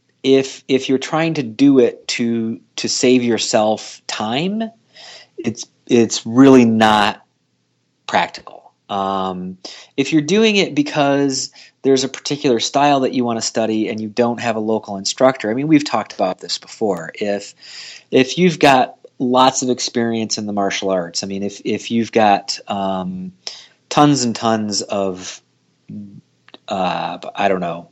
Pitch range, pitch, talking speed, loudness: 105-135 Hz, 115 Hz, 155 wpm, -17 LUFS